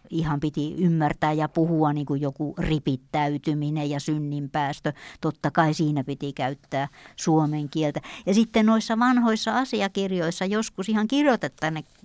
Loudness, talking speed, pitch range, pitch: -25 LUFS, 130 wpm, 150-190 Hz, 155 Hz